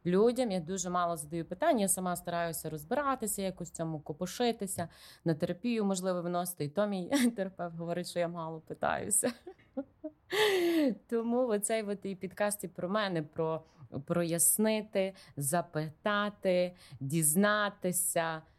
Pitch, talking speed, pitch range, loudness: 180 Hz, 120 wpm, 170-210 Hz, -32 LUFS